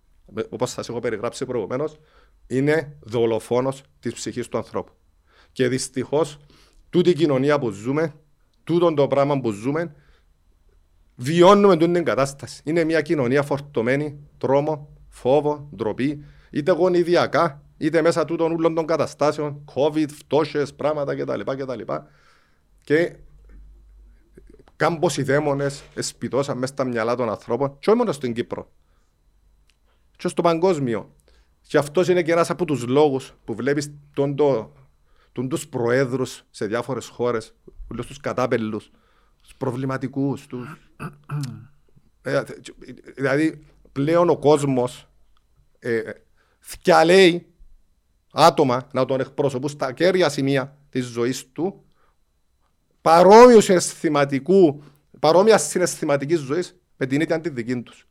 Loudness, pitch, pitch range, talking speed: -21 LUFS, 140 Hz, 125-160 Hz, 115 wpm